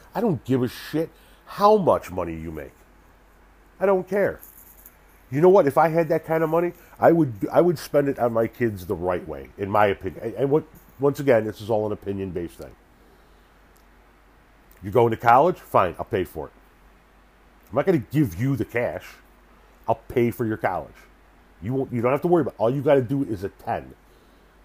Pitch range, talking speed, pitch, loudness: 95-155 Hz, 210 wpm, 120 Hz, -23 LUFS